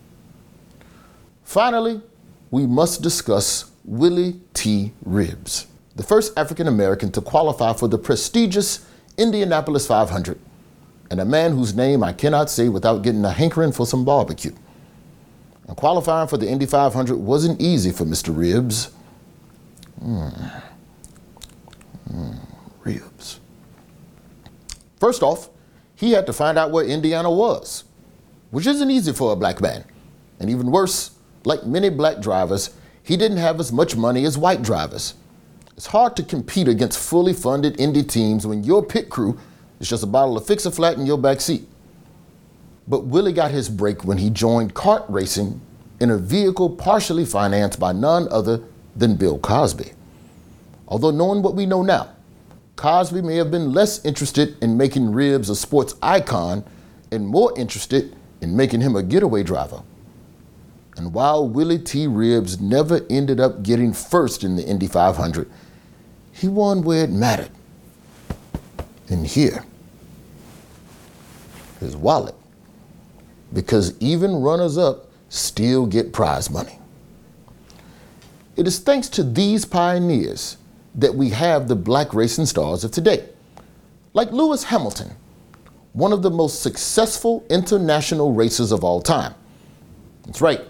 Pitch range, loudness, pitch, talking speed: 115-175 Hz, -19 LUFS, 145 Hz, 140 wpm